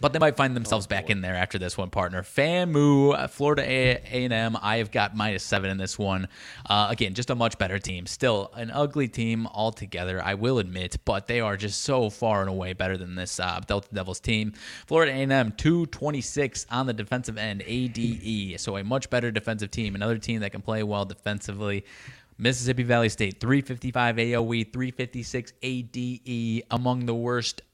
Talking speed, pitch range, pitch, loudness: 190 wpm, 100-125 Hz, 115 Hz, -26 LUFS